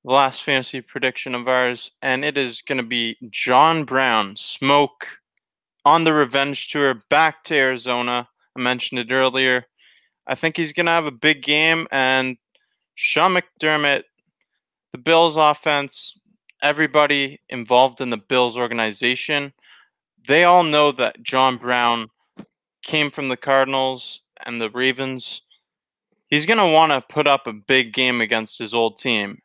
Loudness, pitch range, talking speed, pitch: -19 LUFS, 125-150 Hz, 145 wpm, 130 Hz